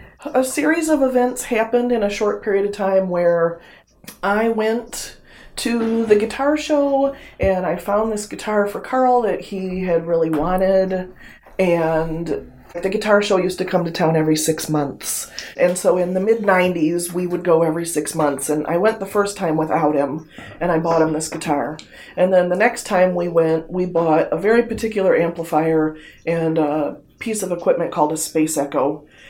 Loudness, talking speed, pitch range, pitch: -19 LUFS, 185 wpm, 160-215 Hz, 180 Hz